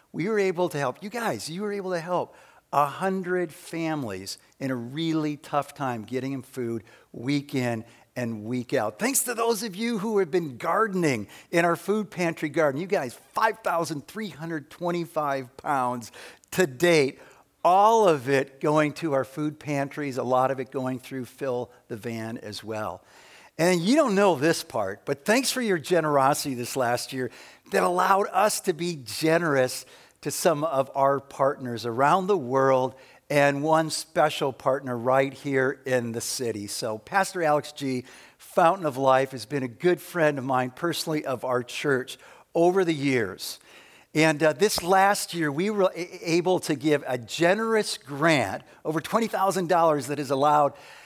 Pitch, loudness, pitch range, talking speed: 150 Hz, -25 LUFS, 130-175 Hz, 165 wpm